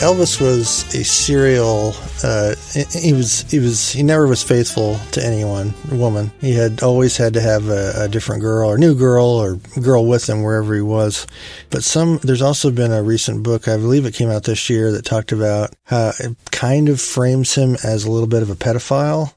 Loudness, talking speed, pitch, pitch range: -16 LUFS, 210 wpm, 120 Hz, 110-130 Hz